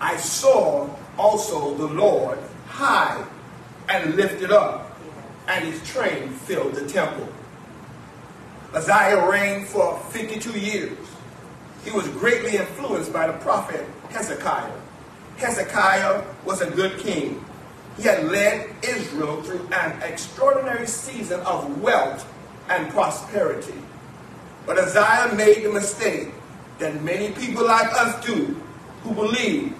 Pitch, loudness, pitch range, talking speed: 210 Hz, -22 LUFS, 185-225 Hz, 115 wpm